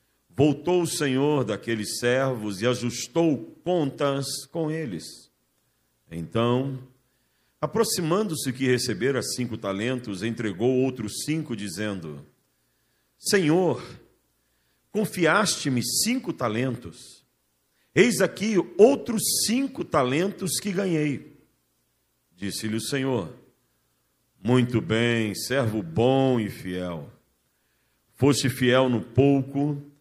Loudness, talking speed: -25 LUFS, 90 wpm